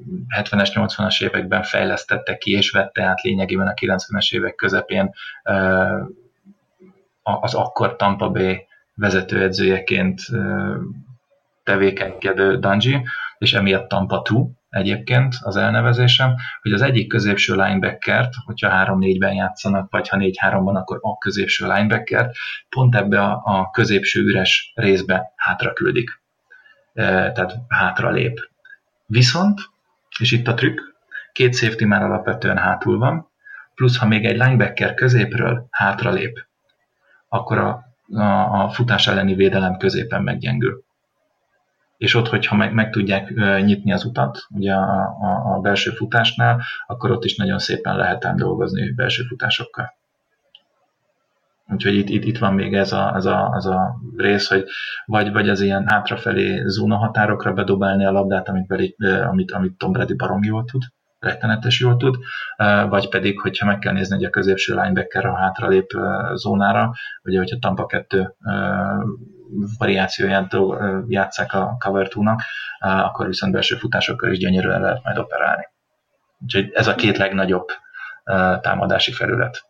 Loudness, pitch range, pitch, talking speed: -19 LUFS, 95-115 Hz, 100 Hz, 135 wpm